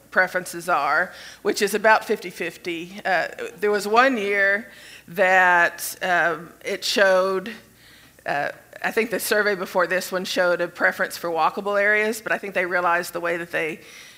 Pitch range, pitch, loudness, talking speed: 175-205 Hz, 185 Hz, -21 LUFS, 165 wpm